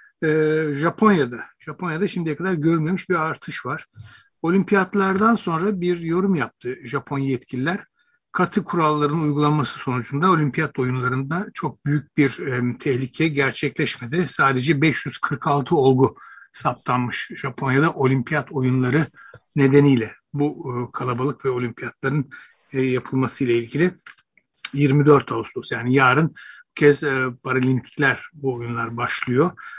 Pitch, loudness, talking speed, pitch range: 145 Hz, -21 LUFS, 110 wpm, 130-165 Hz